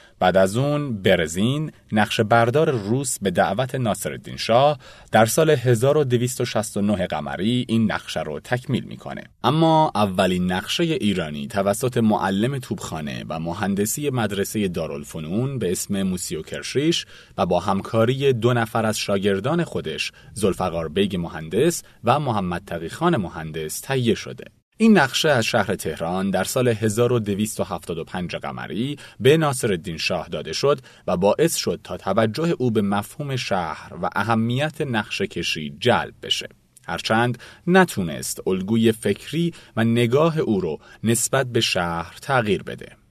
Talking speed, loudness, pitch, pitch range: 130 wpm, -22 LUFS, 115 Hz, 100-130 Hz